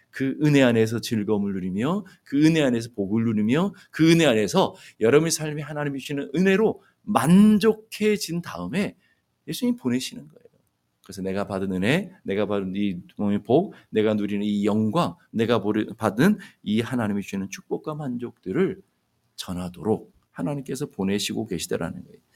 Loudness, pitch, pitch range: -24 LUFS, 120 Hz, 100-160 Hz